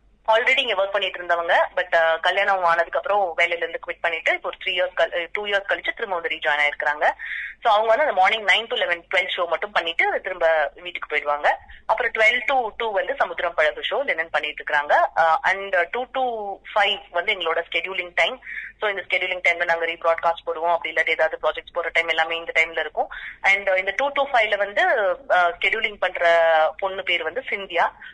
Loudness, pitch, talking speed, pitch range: -21 LUFS, 175 Hz, 185 wpm, 165-200 Hz